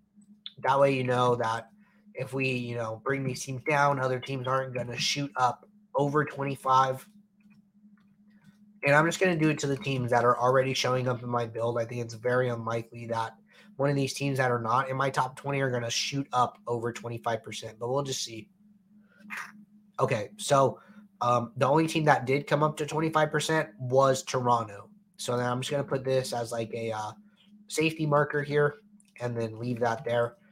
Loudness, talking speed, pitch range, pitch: -28 LUFS, 200 wpm, 120-160 Hz, 135 Hz